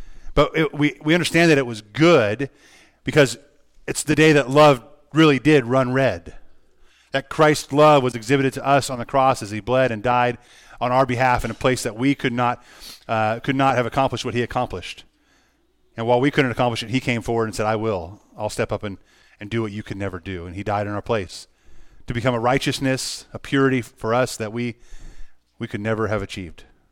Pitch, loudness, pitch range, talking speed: 125 Hz, -20 LUFS, 110-135 Hz, 215 wpm